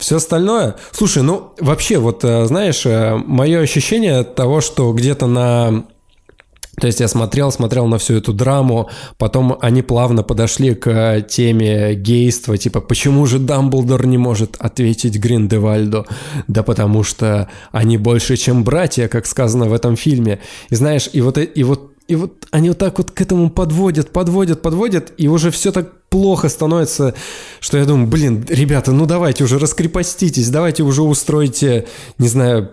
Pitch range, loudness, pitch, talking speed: 115-155 Hz, -14 LUFS, 130 Hz, 160 wpm